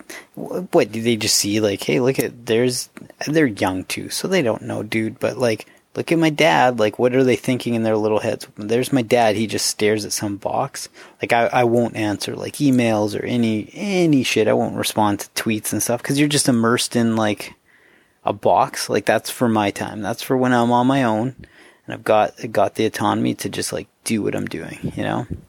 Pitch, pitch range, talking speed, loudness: 115 Hz, 105-125 Hz, 225 wpm, -19 LUFS